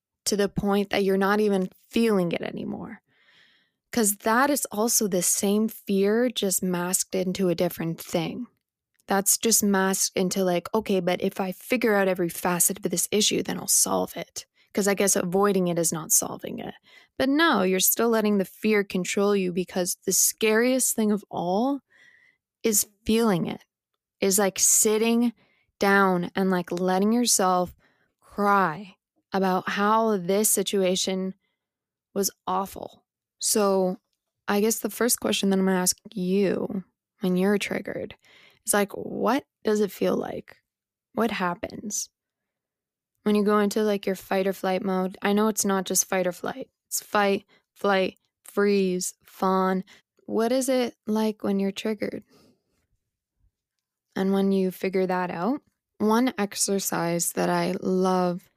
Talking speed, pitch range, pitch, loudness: 155 wpm, 185-215 Hz, 200 Hz, -24 LUFS